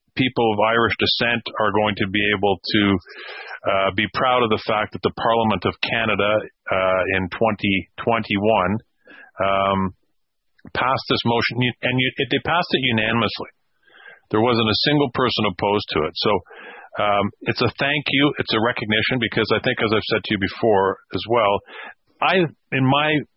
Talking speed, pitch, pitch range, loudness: 170 wpm, 110 Hz, 105-125 Hz, -20 LUFS